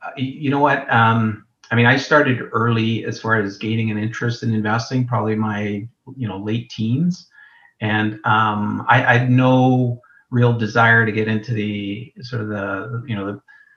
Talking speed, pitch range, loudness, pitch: 180 wpm, 110-125 Hz, -18 LUFS, 115 Hz